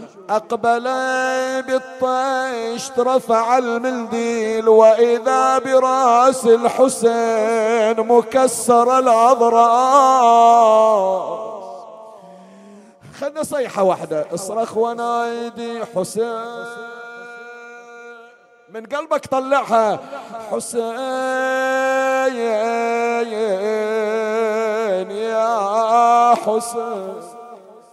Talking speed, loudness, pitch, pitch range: 45 wpm, -17 LUFS, 235 Hz, 225-255 Hz